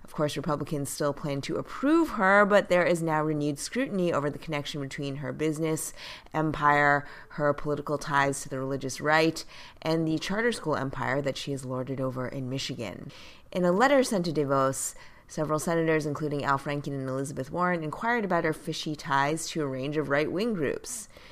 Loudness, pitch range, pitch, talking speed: -28 LUFS, 140-165 Hz, 150 Hz, 185 wpm